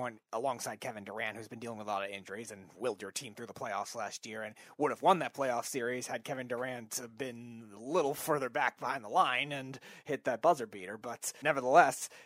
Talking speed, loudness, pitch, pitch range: 220 wpm, -34 LUFS, 120 Hz, 110-125 Hz